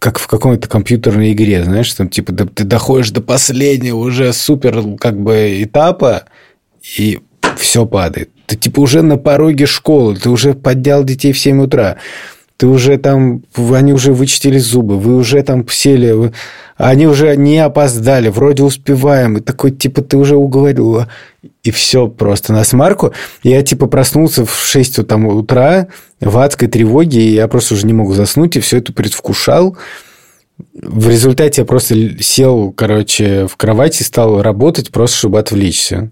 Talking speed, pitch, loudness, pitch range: 160 wpm, 125 Hz, -10 LUFS, 110-140 Hz